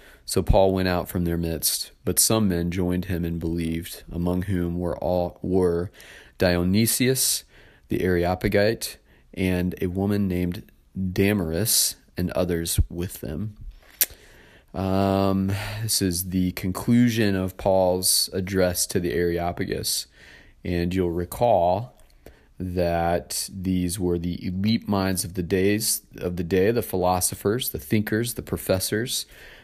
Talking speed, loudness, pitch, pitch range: 130 wpm, -24 LUFS, 90 Hz, 90-100 Hz